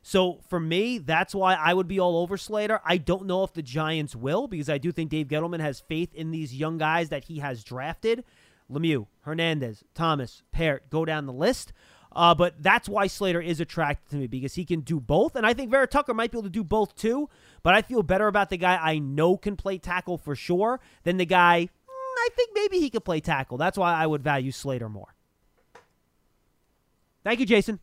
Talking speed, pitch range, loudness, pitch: 220 wpm, 155-205 Hz, -26 LUFS, 175 Hz